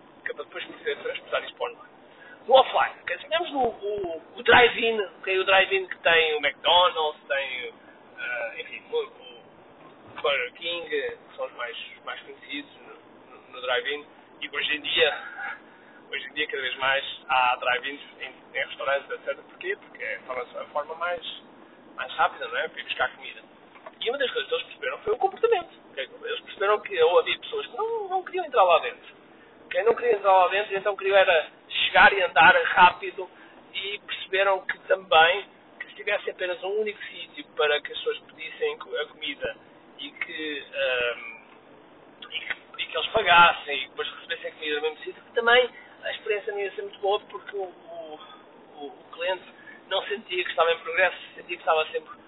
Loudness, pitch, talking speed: -25 LUFS, 290 Hz, 190 wpm